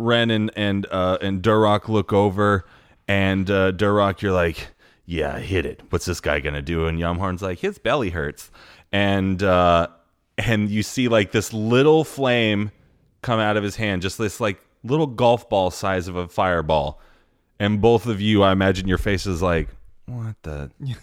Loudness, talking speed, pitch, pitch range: -21 LUFS, 180 wpm, 100 Hz, 90-110 Hz